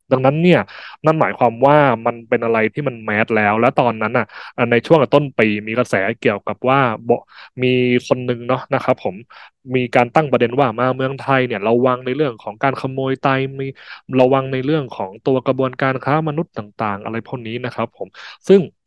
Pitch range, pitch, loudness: 120-135 Hz, 130 Hz, -17 LUFS